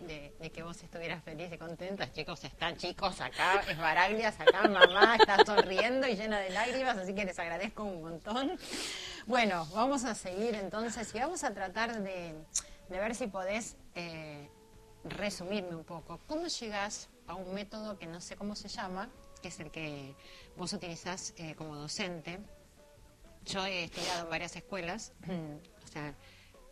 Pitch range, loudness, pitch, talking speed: 165-210 Hz, -33 LUFS, 185 Hz, 165 wpm